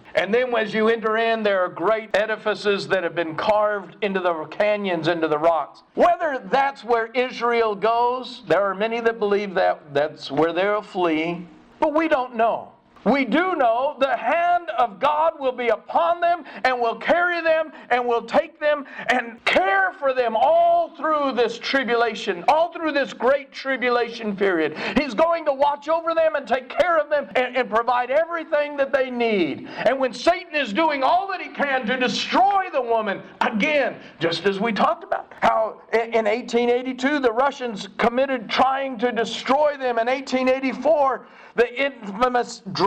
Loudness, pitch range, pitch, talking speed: -21 LUFS, 220-290 Hz, 245 Hz, 170 wpm